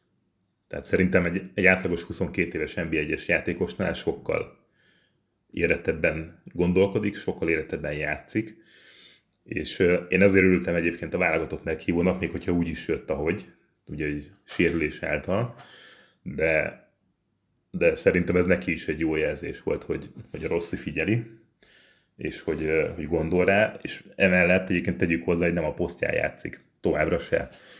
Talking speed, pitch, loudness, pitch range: 145 wpm, 90 Hz, -25 LUFS, 85-100 Hz